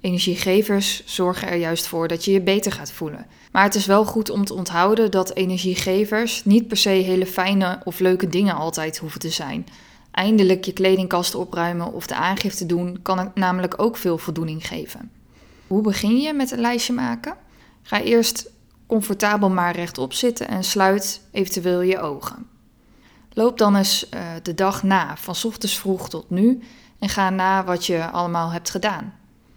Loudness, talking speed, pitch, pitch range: -21 LUFS, 175 wpm, 190 Hz, 180-210 Hz